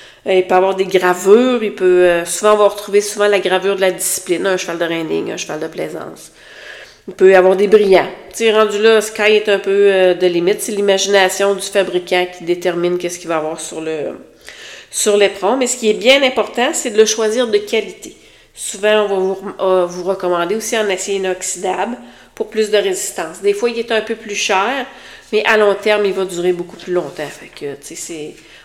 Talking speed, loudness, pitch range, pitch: 230 wpm, -15 LUFS, 180-215 Hz, 195 Hz